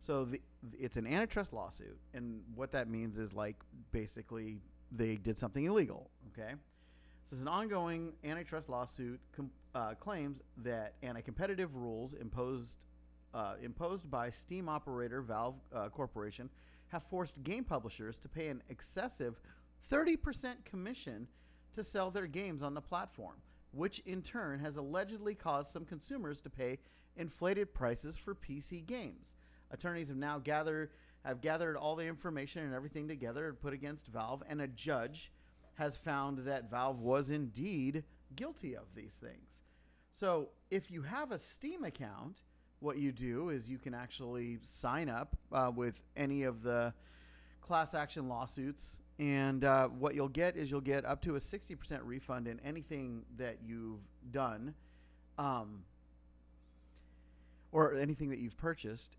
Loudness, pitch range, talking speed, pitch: -41 LUFS, 115-155 Hz, 150 wpm, 135 Hz